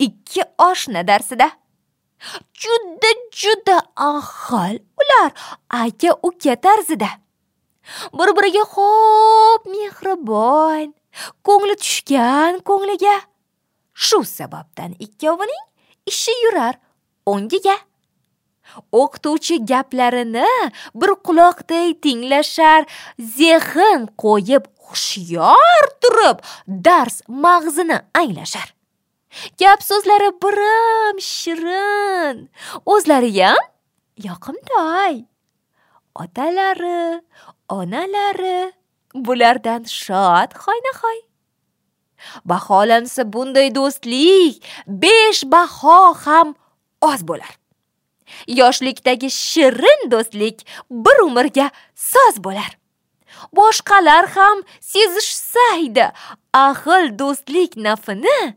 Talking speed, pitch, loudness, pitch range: 70 wpm, 335 Hz, -15 LUFS, 255-400 Hz